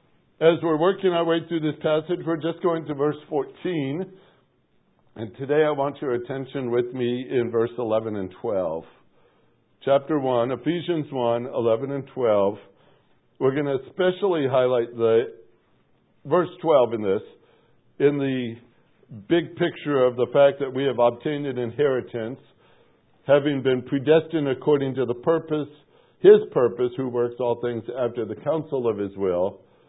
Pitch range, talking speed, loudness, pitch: 120-160 Hz, 155 wpm, -23 LUFS, 140 Hz